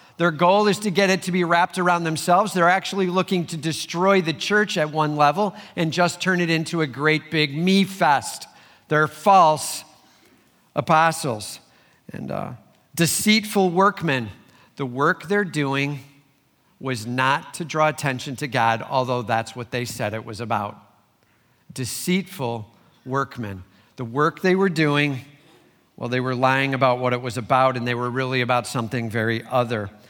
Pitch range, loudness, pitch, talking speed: 125-175 Hz, -21 LUFS, 145 Hz, 160 wpm